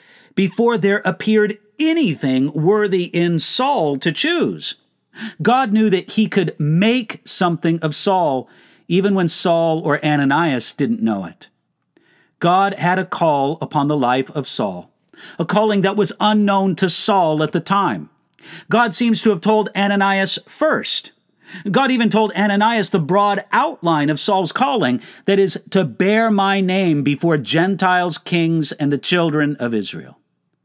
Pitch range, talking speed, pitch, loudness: 160-210 Hz, 150 wpm, 190 Hz, -17 LUFS